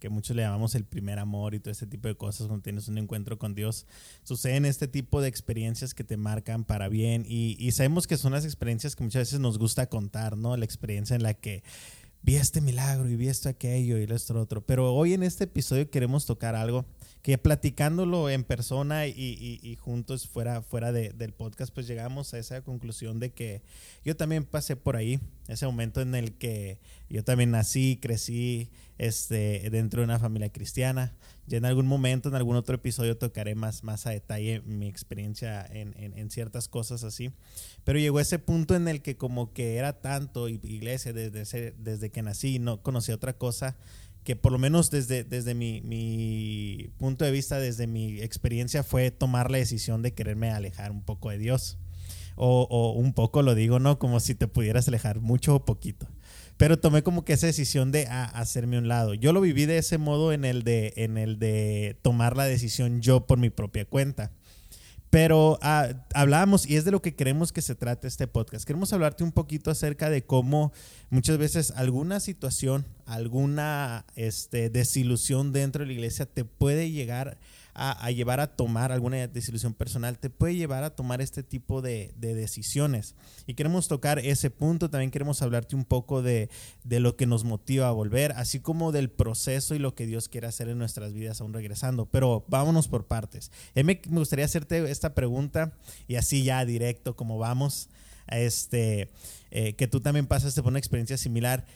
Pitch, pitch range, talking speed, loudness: 125 Hz, 115-135 Hz, 195 wpm, -28 LUFS